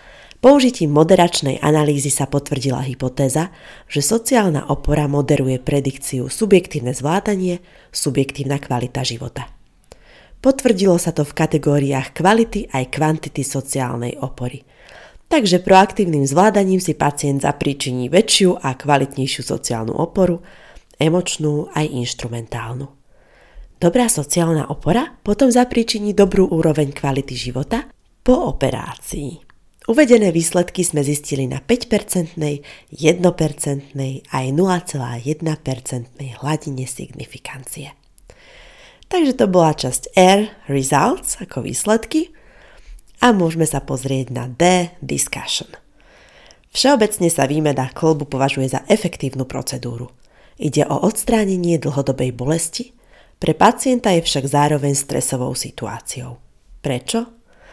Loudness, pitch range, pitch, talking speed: -18 LUFS, 135-190 Hz, 150 Hz, 105 wpm